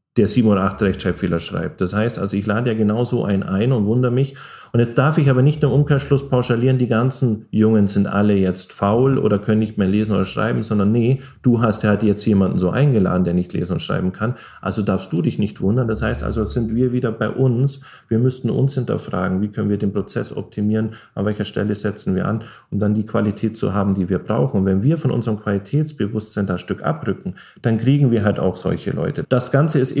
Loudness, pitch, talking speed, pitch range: -19 LUFS, 110 Hz, 235 wpm, 100-125 Hz